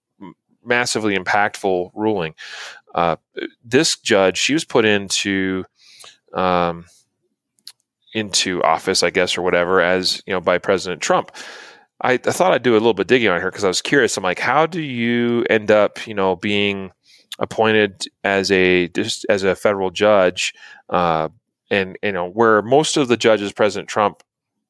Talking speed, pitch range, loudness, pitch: 165 wpm, 90-110 Hz, -18 LUFS, 100 Hz